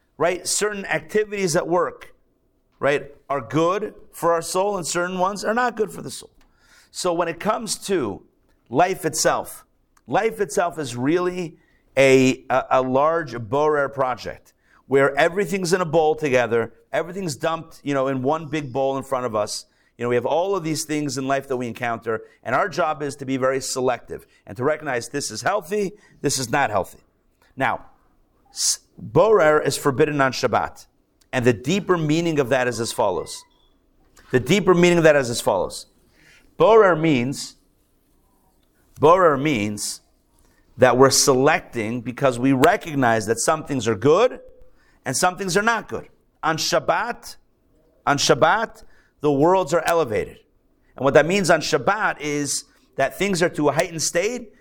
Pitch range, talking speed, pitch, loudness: 130-180 Hz, 165 wpm, 155 Hz, -21 LUFS